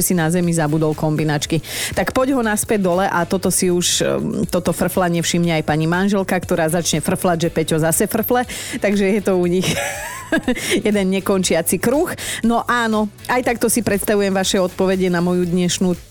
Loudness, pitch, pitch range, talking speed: -18 LUFS, 185 Hz, 170-215 Hz, 170 wpm